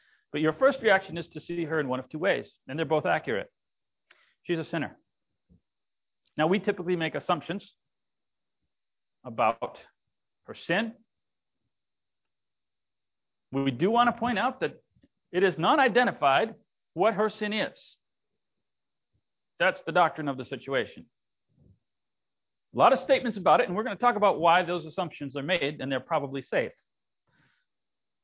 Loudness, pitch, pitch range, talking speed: -27 LUFS, 170 Hz, 150-210 Hz, 150 wpm